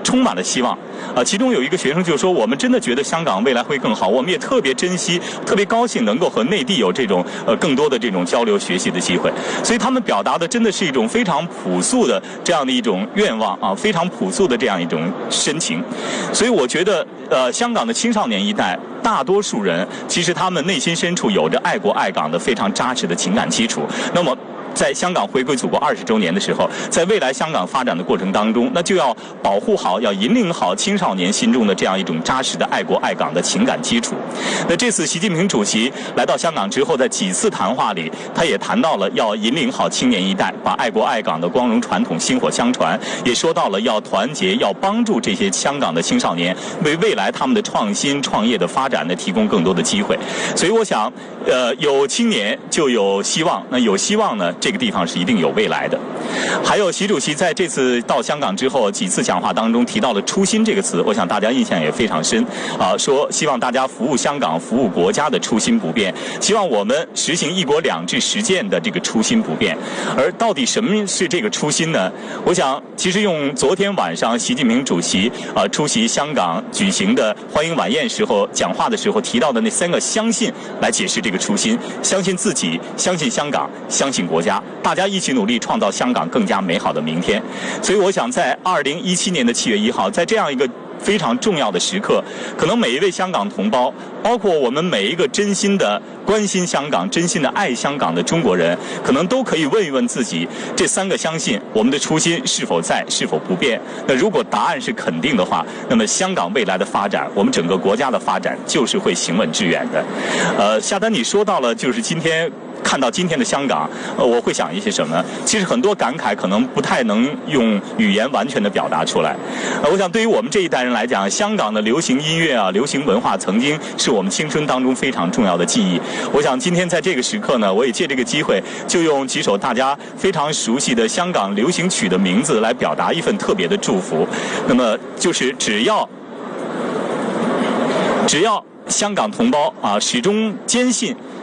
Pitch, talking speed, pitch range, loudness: 210 Hz, 320 characters per minute, 185-235 Hz, -17 LUFS